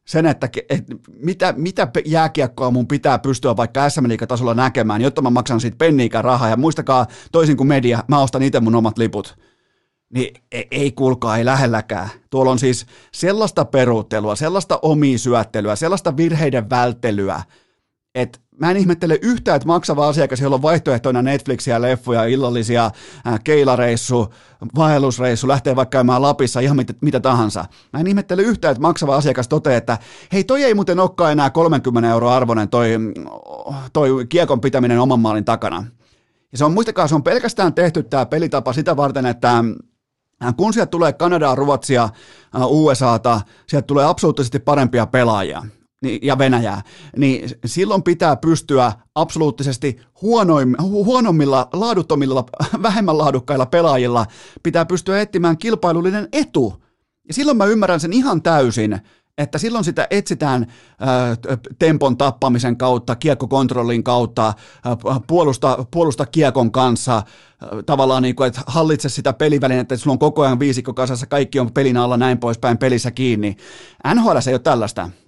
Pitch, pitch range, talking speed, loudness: 135 Hz, 120-155 Hz, 150 wpm, -17 LUFS